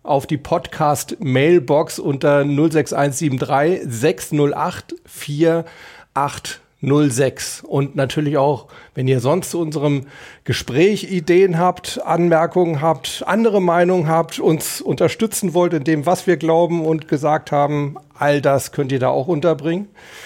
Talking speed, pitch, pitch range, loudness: 125 wpm, 155 Hz, 145-175 Hz, -18 LUFS